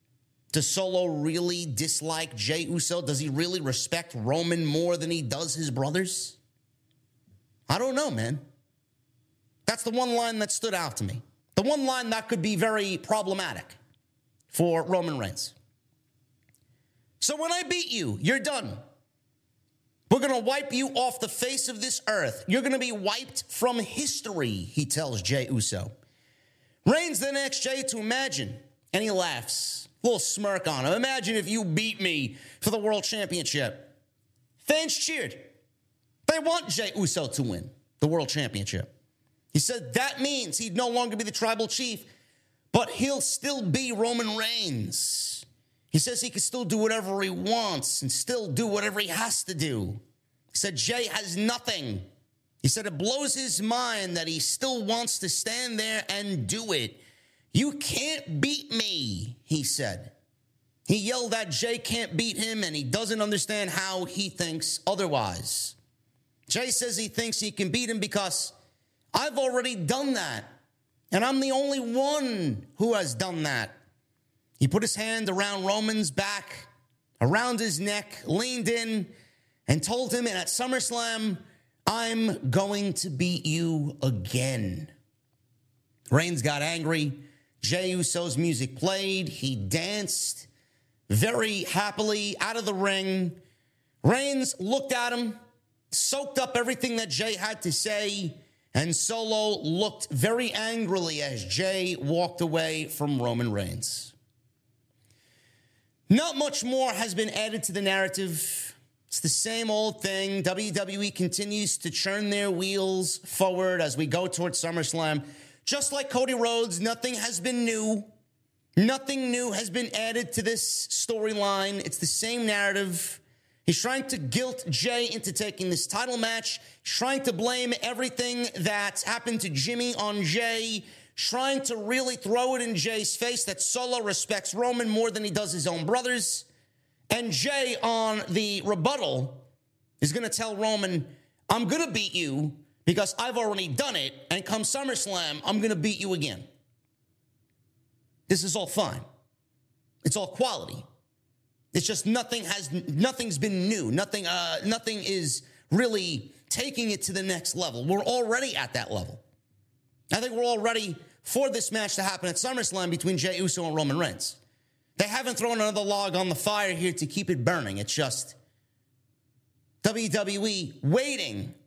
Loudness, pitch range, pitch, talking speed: -28 LUFS, 140-225 Hz, 185 Hz, 155 wpm